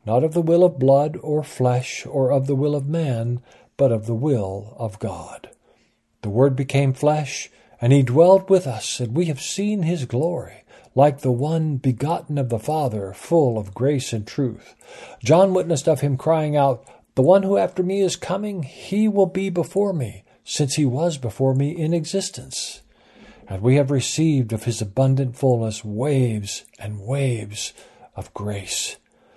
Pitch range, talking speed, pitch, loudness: 120-160 Hz, 175 wpm, 140 Hz, -21 LUFS